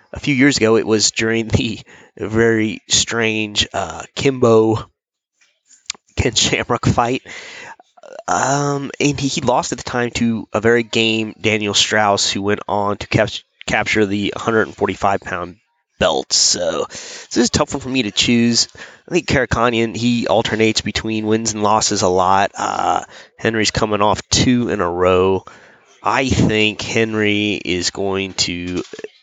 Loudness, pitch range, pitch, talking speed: -17 LUFS, 105-120 Hz, 110 Hz, 150 wpm